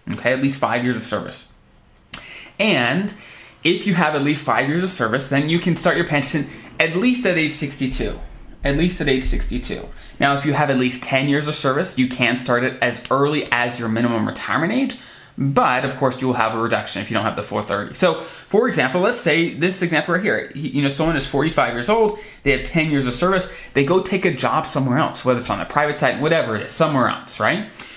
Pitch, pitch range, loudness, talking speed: 140 Hz, 125-165 Hz, -19 LUFS, 235 wpm